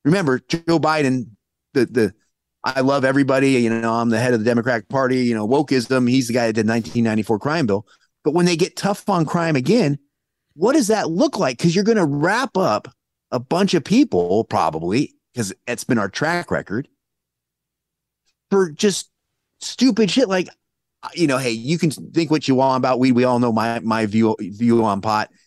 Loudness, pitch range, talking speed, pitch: -19 LUFS, 115-170 Hz, 205 wpm, 135 Hz